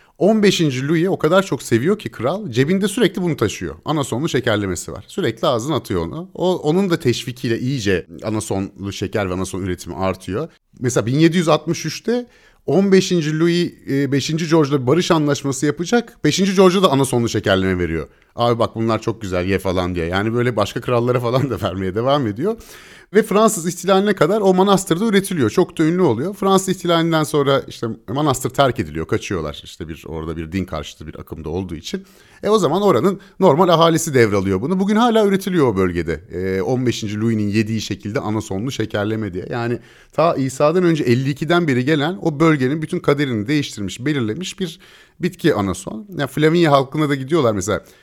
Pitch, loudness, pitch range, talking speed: 140 Hz, -18 LUFS, 105-175 Hz, 165 wpm